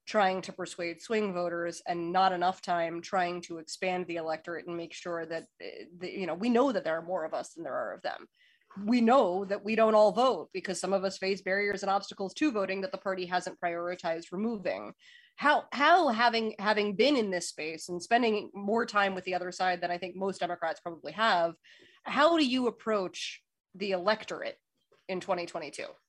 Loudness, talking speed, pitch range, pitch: -30 LUFS, 205 wpm, 175-220 Hz, 190 Hz